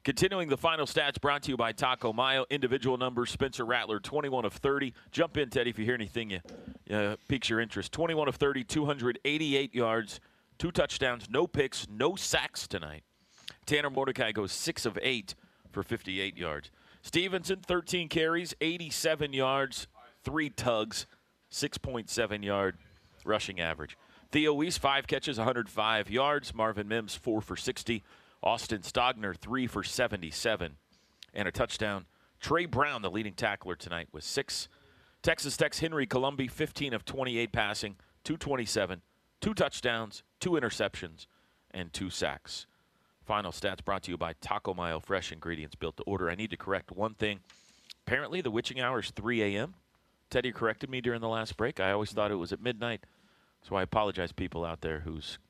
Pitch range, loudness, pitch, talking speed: 100-140 Hz, -32 LUFS, 115 Hz, 165 wpm